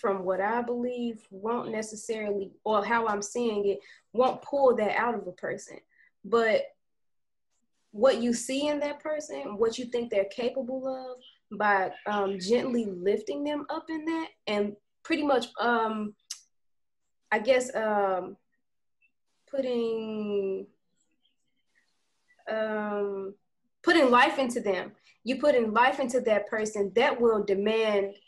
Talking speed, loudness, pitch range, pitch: 130 wpm, -28 LUFS, 205-255 Hz, 230 Hz